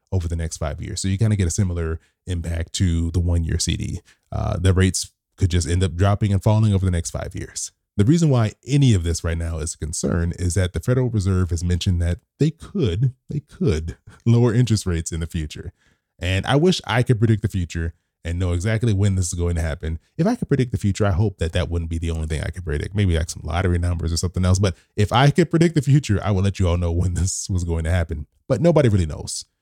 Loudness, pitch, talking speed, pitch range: -21 LUFS, 95 Hz, 255 wpm, 85-105 Hz